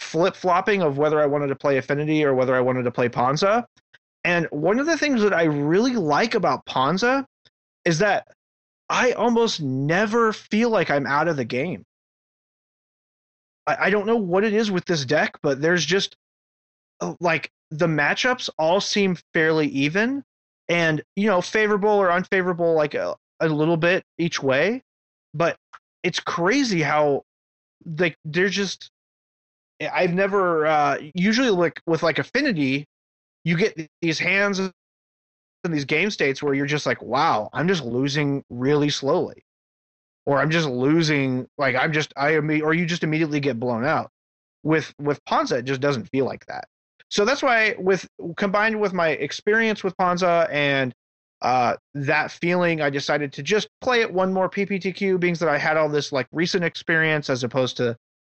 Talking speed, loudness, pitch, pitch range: 170 wpm, -22 LUFS, 160 Hz, 140-190 Hz